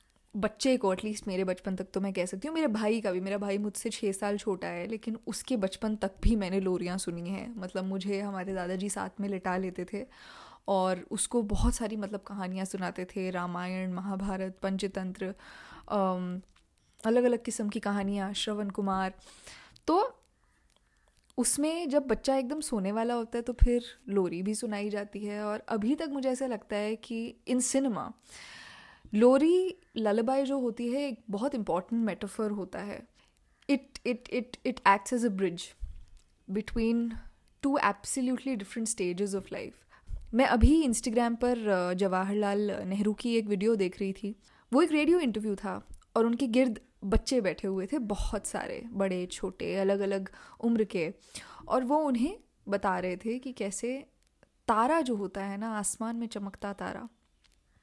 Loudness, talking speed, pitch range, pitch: -31 LUFS, 165 wpm, 195-245 Hz, 210 Hz